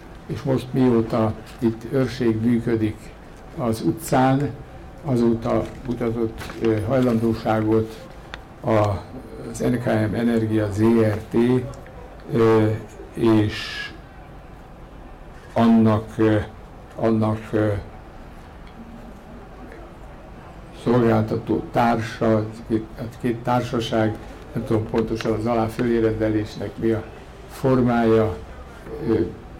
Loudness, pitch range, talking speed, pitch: -22 LUFS, 110-115 Hz, 60 wpm, 110 Hz